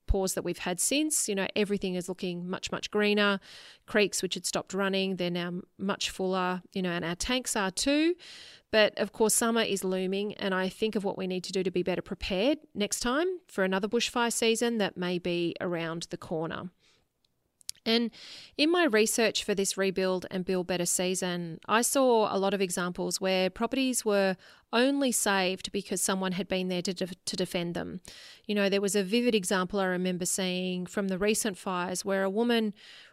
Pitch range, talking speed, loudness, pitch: 185-215 Hz, 195 wpm, -29 LUFS, 195 Hz